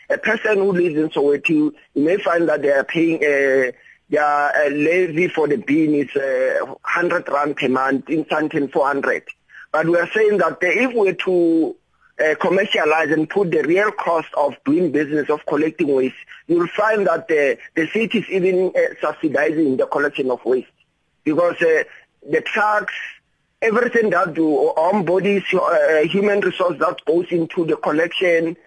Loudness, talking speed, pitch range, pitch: -18 LUFS, 170 wpm, 155-205 Hz, 175 Hz